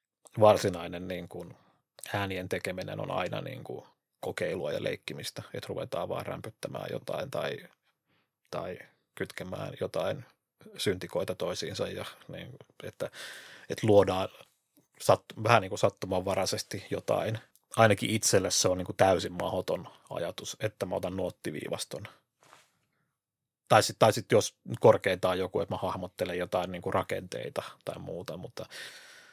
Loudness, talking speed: -30 LUFS, 120 wpm